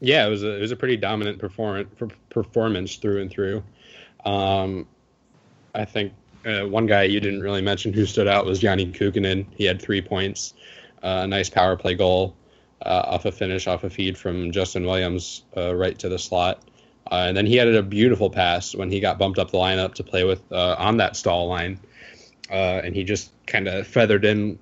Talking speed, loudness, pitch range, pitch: 210 wpm, -22 LUFS, 95-105 Hz, 100 Hz